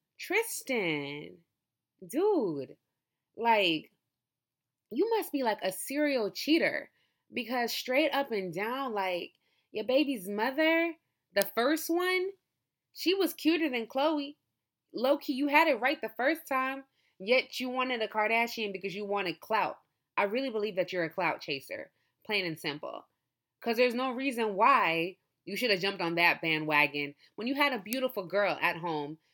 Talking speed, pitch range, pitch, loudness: 155 wpm, 180-280 Hz, 230 Hz, -30 LUFS